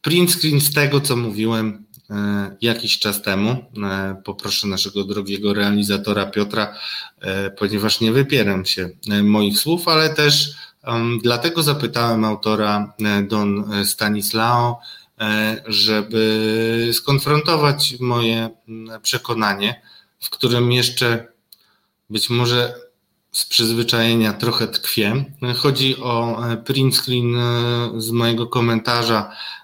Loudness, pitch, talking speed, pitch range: -18 LUFS, 115 Hz, 95 wpm, 105-125 Hz